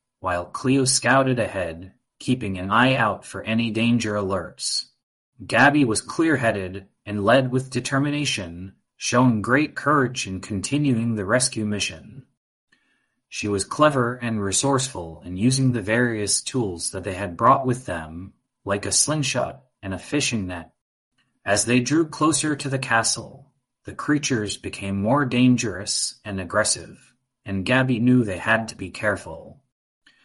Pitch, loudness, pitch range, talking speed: 115 Hz, -22 LUFS, 100-130 Hz, 145 wpm